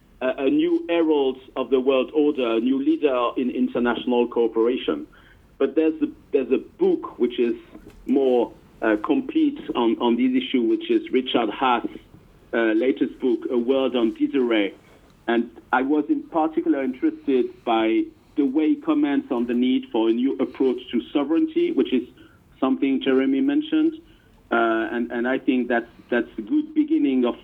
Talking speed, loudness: 165 wpm, -22 LUFS